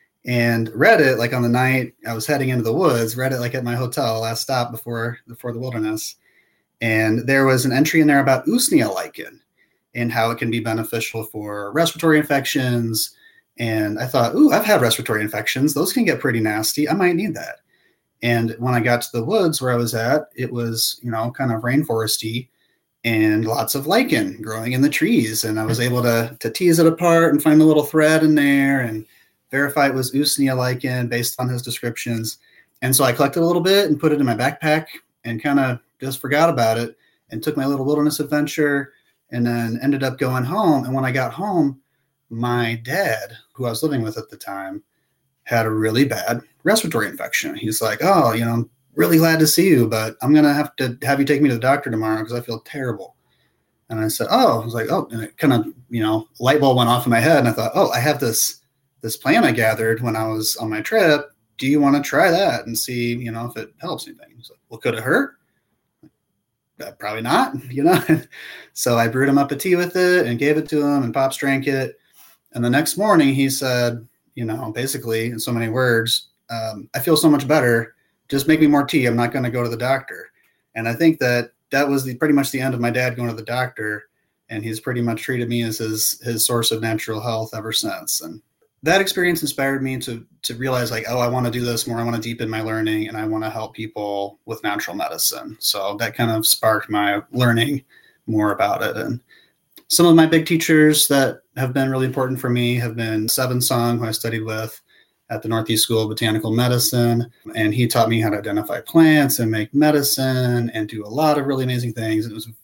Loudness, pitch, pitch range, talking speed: -19 LUFS, 120 Hz, 115-140 Hz, 230 wpm